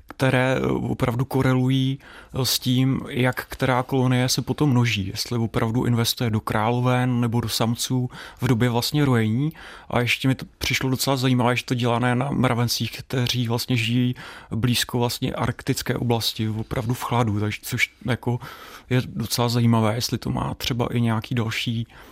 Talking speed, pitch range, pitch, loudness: 155 wpm, 115-130 Hz, 125 Hz, -23 LUFS